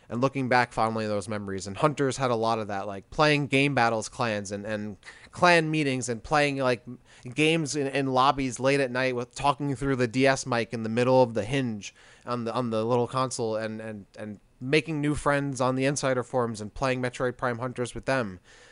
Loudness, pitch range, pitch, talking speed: -26 LUFS, 115-135 Hz, 125 Hz, 220 wpm